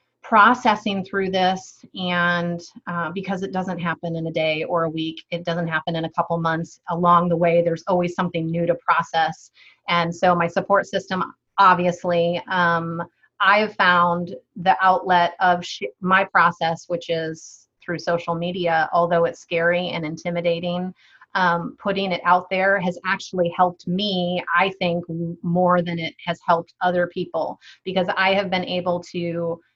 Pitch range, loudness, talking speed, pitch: 170-185 Hz, -21 LUFS, 165 wpm, 175 Hz